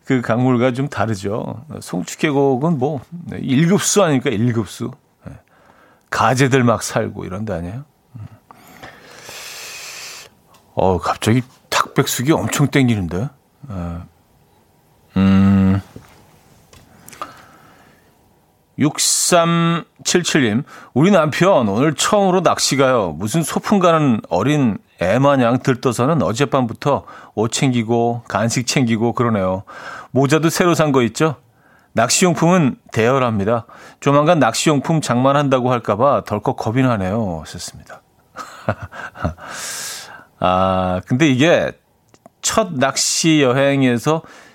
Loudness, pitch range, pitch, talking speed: -17 LUFS, 115-150 Hz, 130 Hz, 205 characters per minute